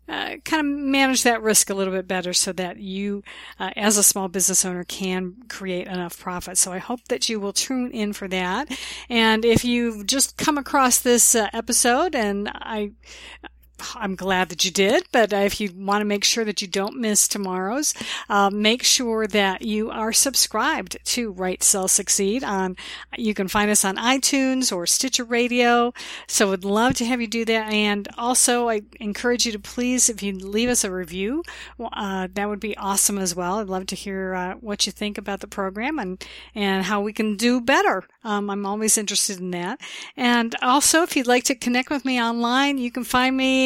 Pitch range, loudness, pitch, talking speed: 195-245 Hz, -21 LUFS, 215 Hz, 205 wpm